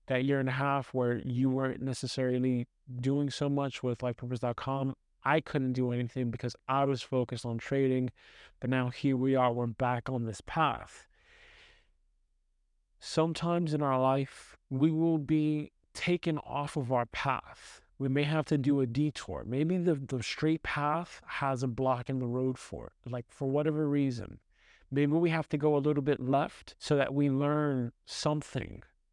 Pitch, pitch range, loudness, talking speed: 135 Hz, 125-150 Hz, -32 LUFS, 175 wpm